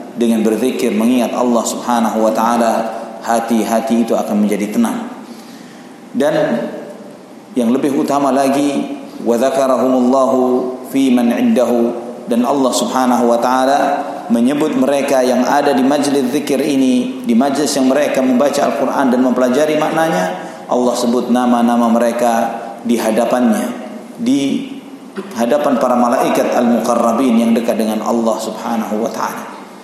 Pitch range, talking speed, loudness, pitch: 115-155 Hz, 125 wpm, -14 LUFS, 125 Hz